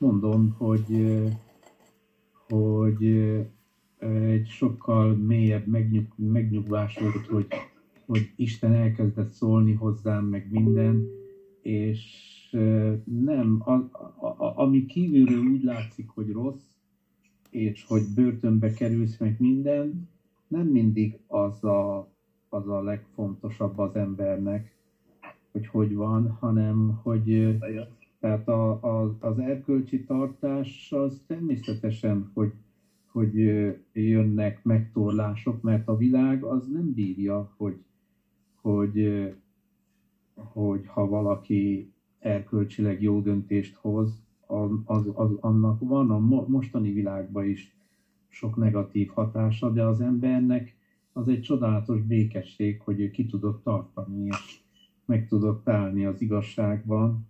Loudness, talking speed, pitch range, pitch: -26 LUFS, 110 wpm, 105-115 Hz, 110 Hz